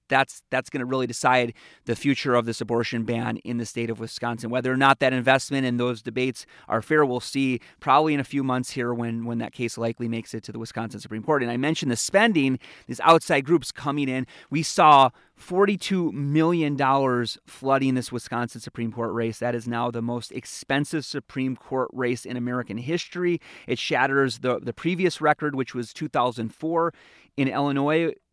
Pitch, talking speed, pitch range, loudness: 130 Hz, 195 wpm, 120-145 Hz, -24 LUFS